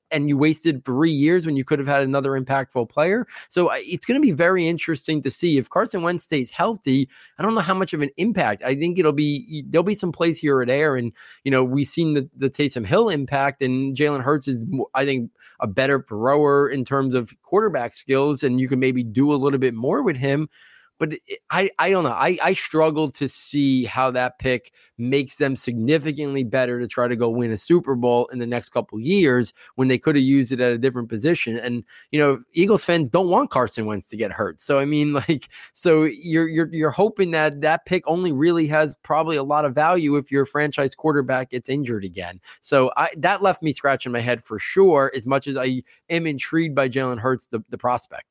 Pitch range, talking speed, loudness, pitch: 130-160 Hz, 225 wpm, -21 LUFS, 140 Hz